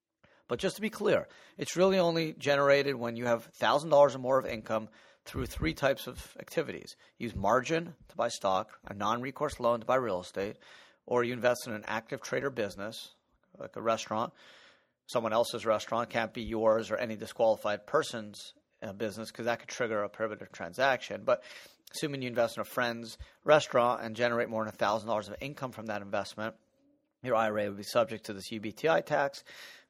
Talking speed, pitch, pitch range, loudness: 180 wpm, 120 Hz, 110-140 Hz, -31 LUFS